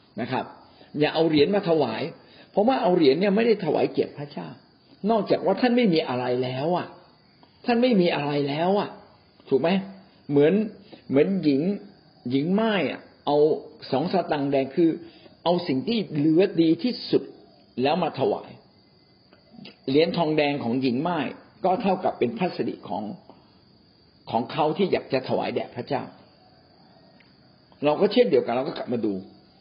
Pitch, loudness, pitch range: 155 Hz, -24 LUFS, 140-195 Hz